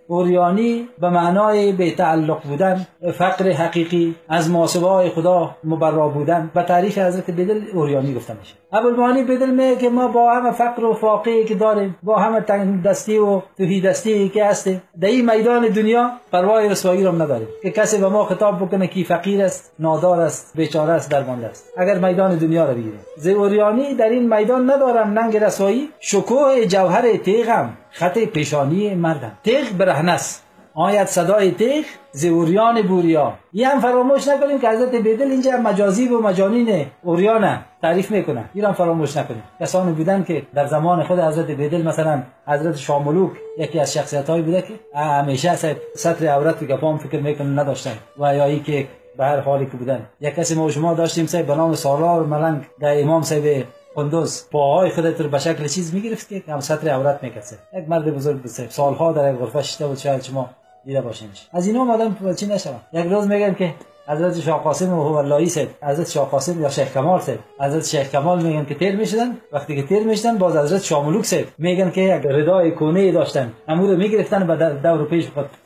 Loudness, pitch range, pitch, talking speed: -18 LUFS, 150-205 Hz, 175 Hz, 180 wpm